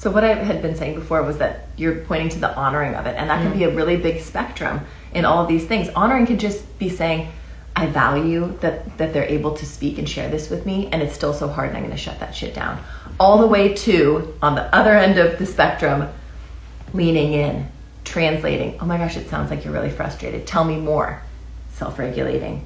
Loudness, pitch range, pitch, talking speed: -20 LUFS, 150-185 Hz, 160 Hz, 230 wpm